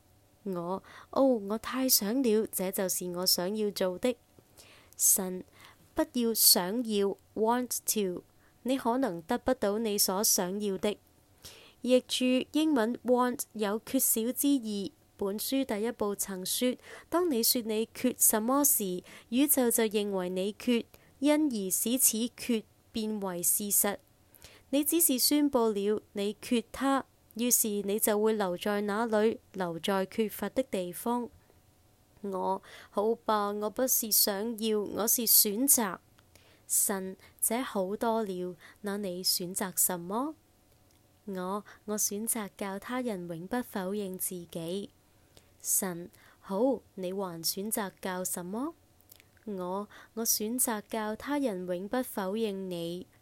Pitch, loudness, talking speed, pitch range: 210 Hz, -29 LUFS, 185 characters per minute, 190-240 Hz